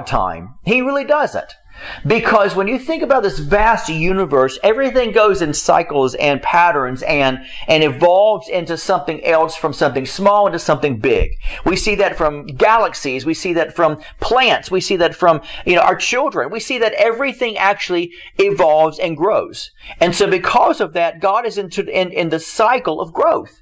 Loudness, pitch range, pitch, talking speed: -15 LUFS, 155-210 Hz, 180 Hz, 180 wpm